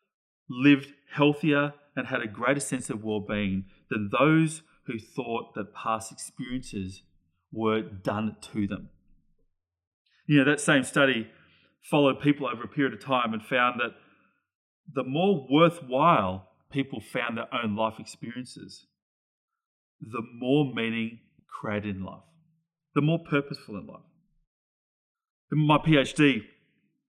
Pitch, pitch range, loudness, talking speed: 130 Hz, 110-150 Hz, -27 LUFS, 130 wpm